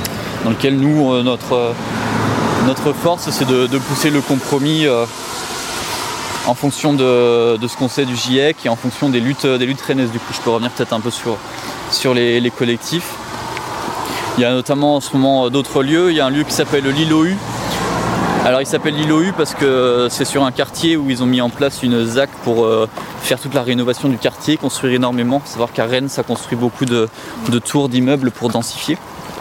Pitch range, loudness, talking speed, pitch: 120-145 Hz, -16 LUFS, 200 wpm, 130 Hz